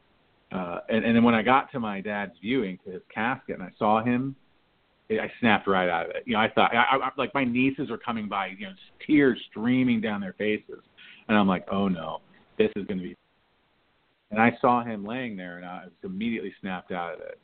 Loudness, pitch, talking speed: -26 LUFS, 115 Hz, 235 wpm